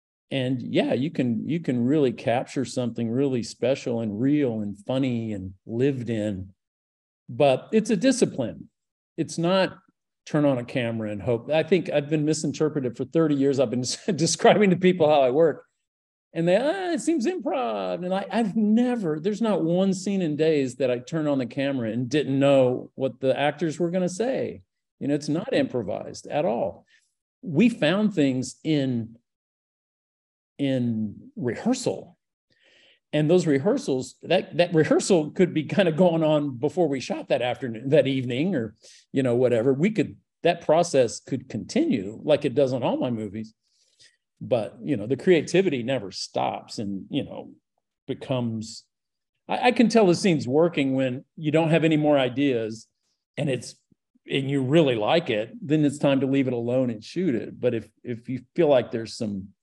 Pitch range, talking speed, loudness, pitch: 120-170 Hz, 180 wpm, -24 LUFS, 140 Hz